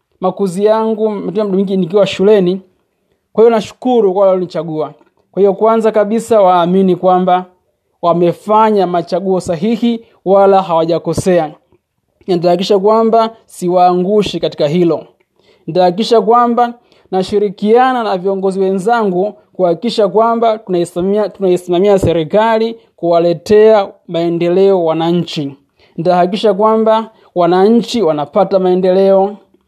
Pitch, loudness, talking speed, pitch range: 195 Hz, -12 LUFS, 80 wpm, 180-215 Hz